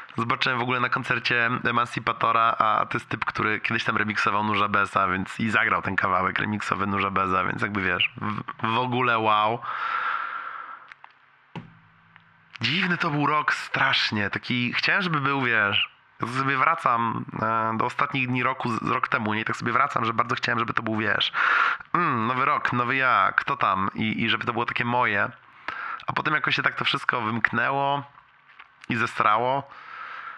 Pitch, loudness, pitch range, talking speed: 115 Hz, -24 LUFS, 105-130 Hz, 170 wpm